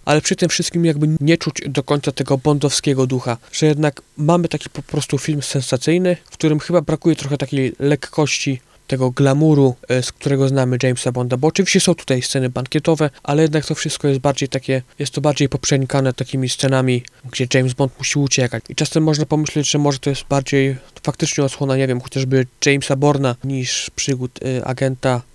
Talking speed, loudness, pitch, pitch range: 185 wpm, -18 LUFS, 140 Hz, 130-155 Hz